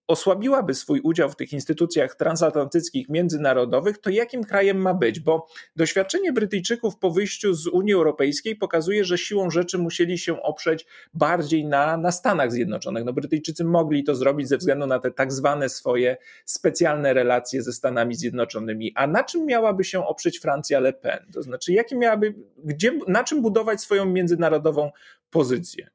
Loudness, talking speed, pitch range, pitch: -23 LUFS, 160 wpm, 145-195 Hz, 170 Hz